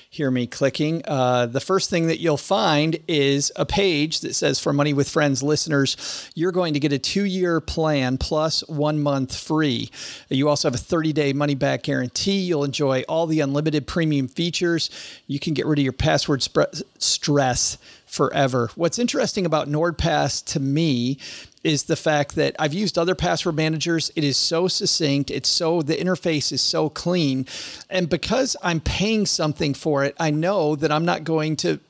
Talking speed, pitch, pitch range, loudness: 185 wpm, 155 Hz, 140-170 Hz, -22 LUFS